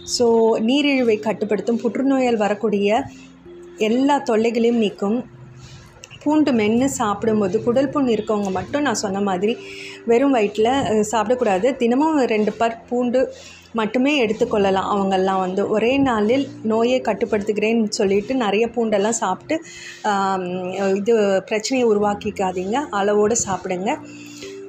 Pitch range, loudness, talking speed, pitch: 195-240 Hz, -19 LUFS, 100 wpm, 220 Hz